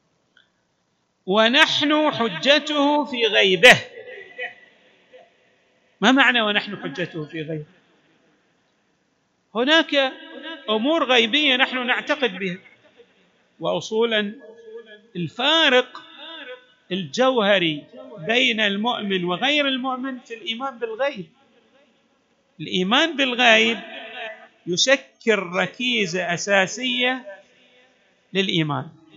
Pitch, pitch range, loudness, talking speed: 235 Hz, 195-270 Hz, -19 LUFS, 65 wpm